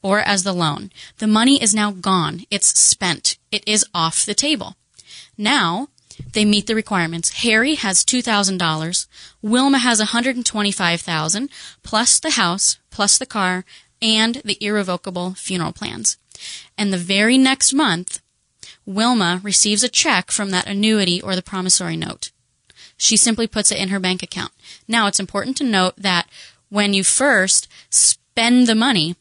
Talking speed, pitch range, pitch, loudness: 150 wpm, 185-225 Hz, 205 Hz, -17 LUFS